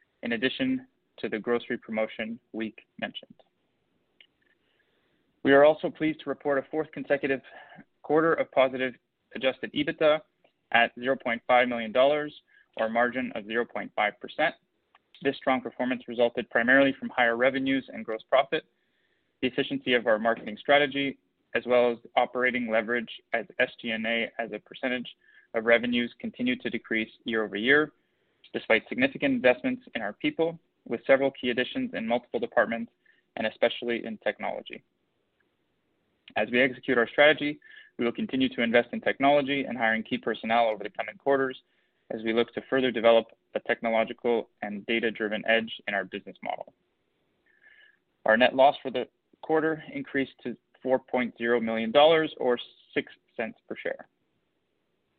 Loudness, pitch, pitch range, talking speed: -27 LUFS, 125 Hz, 115-145 Hz, 145 wpm